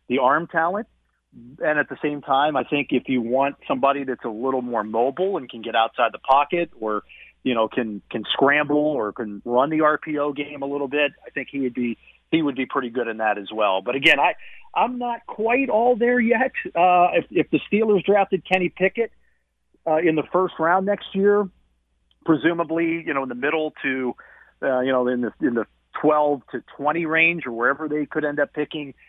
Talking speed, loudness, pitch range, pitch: 210 wpm, -22 LUFS, 125-175 Hz, 145 Hz